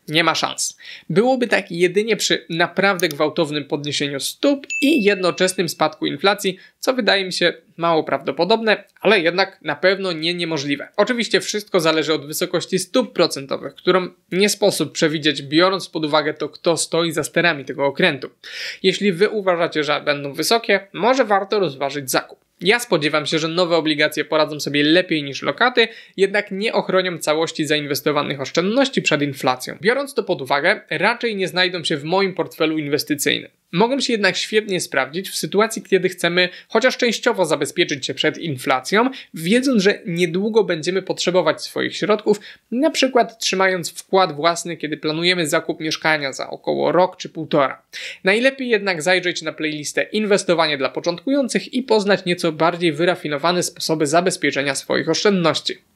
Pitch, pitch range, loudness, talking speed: 175 Hz, 155-200 Hz, -19 LUFS, 150 wpm